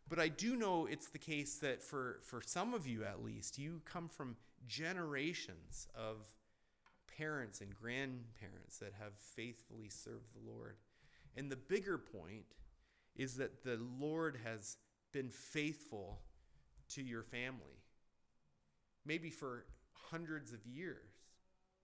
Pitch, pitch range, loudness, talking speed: 125 Hz, 110-150 Hz, -46 LUFS, 130 wpm